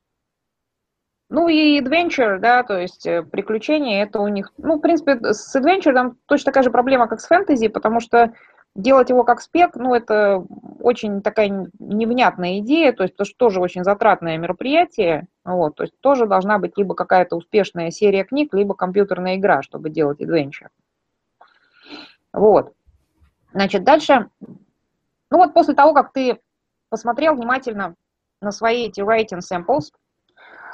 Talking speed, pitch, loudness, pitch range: 145 wpm, 230 Hz, -18 LUFS, 195-275 Hz